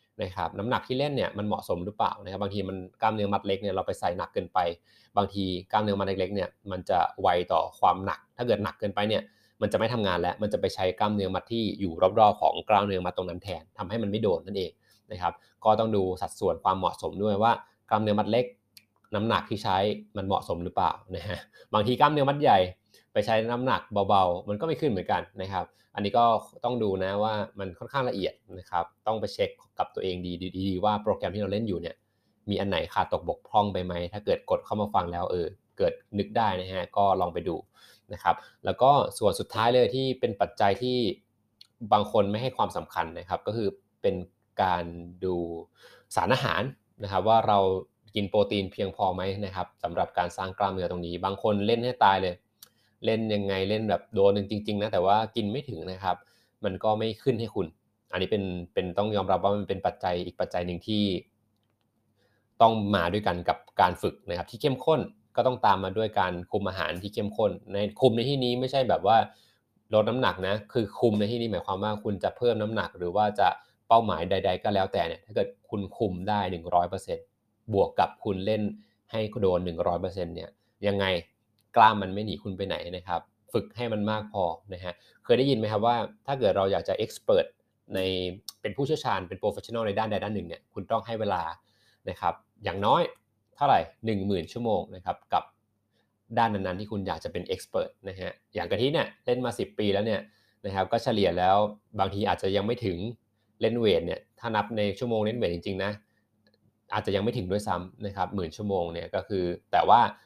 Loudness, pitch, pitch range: -28 LUFS, 105 Hz, 95-110 Hz